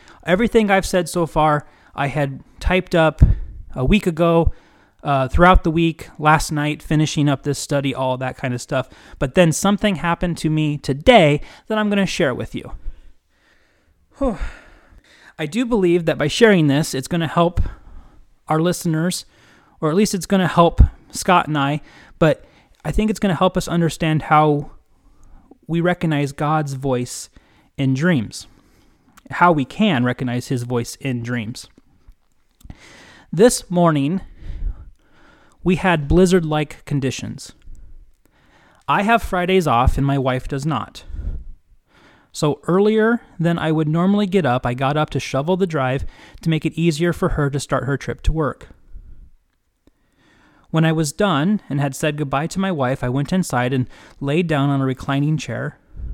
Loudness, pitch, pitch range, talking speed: -19 LUFS, 155 Hz, 135-180 Hz, 165 wpm